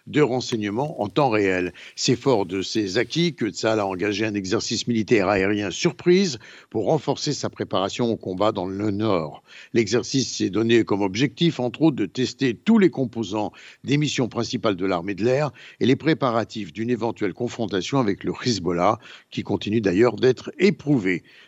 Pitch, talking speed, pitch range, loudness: 115 Hz, 170 wpm, 105-135 Hz, -23 LUFS